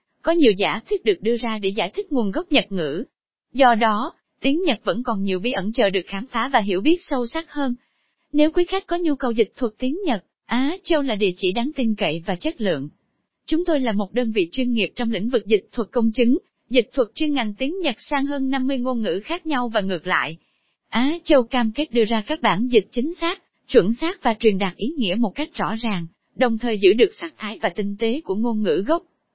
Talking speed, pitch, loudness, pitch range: 245 wpm, 245 Hz, -22 LUFS, 215-295 Hz